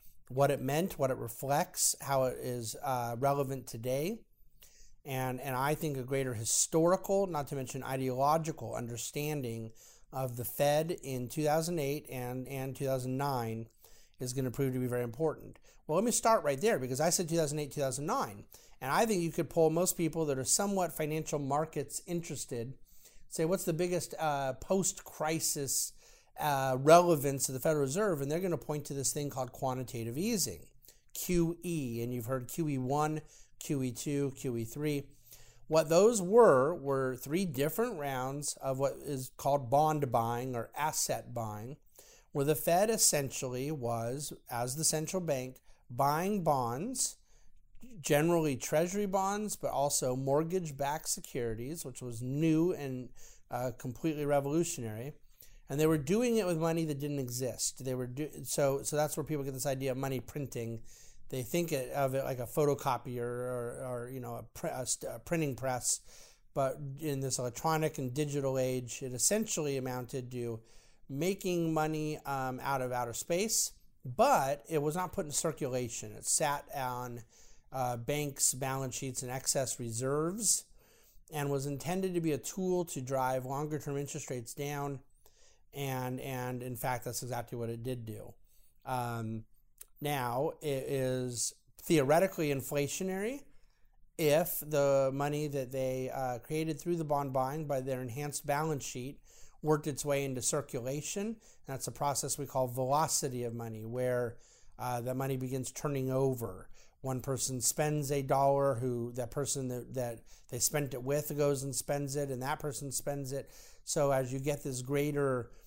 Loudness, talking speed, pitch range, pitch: -33 LUFS, 165 wpm, 125-155 Hz, 140 Hz